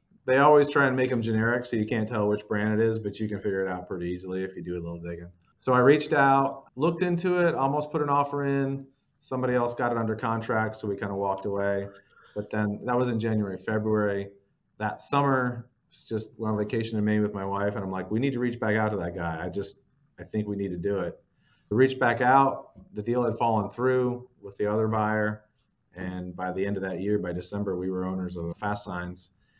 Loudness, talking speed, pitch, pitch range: -27 LUFS, 245 wpm, 110 Hz, 100-125 Hz